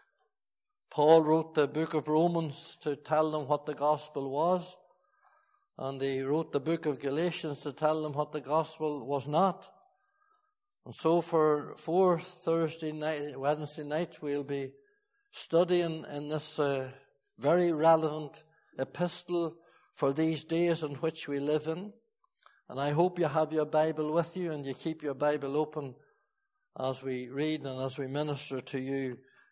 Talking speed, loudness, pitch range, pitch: 155 wpm, -31 LUFS, 145-170 Hz, 155 Hz